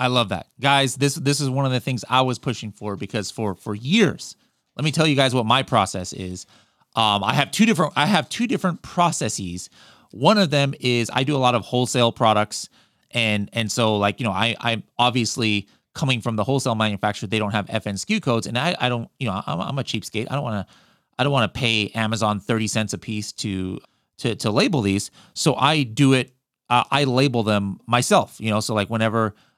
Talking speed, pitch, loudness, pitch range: 225 wpm, 120 Hz, -21 LUFS, 105-135 Hz